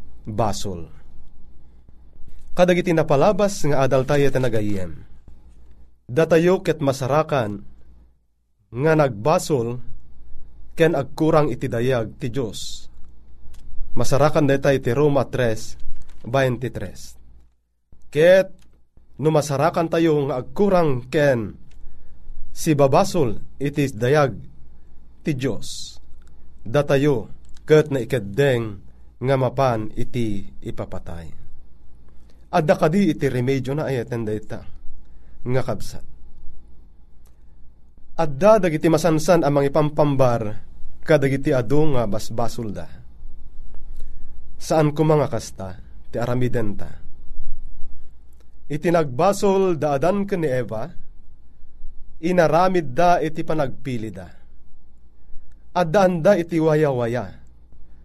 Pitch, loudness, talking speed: 110 Hz, -20 LUFS, 90 wpm